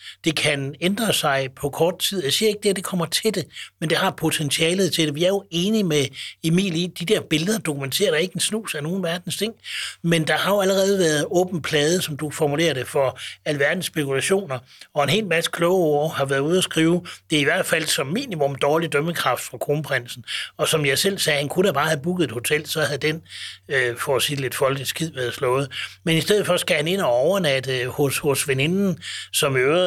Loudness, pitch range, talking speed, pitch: -21 LUFS, 145-180 Hz, 230 wpm, 160 Hz